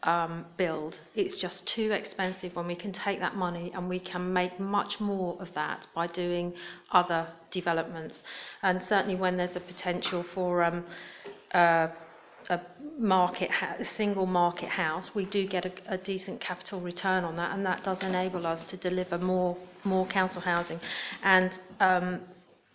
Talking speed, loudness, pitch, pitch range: 165 wpm, -30 LUFS, 180 Hz, 175-190 Hz